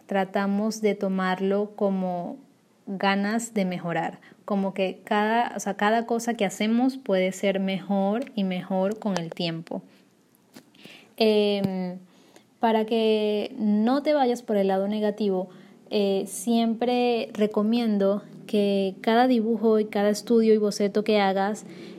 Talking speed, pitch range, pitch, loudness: 130 wpm, 195-225 Hz, 205 Hz, -25 LUFS